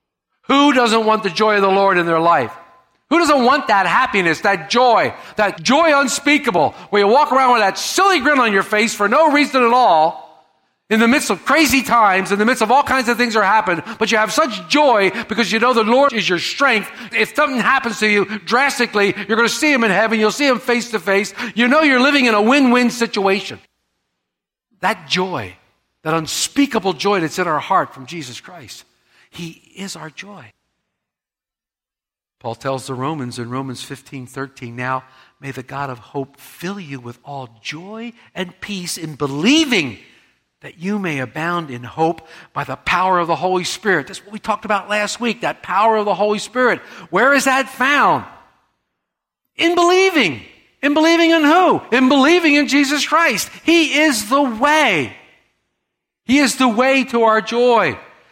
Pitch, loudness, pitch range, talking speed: 215 Hz, -15 LUFS, 170-260 Hz, 190 wpm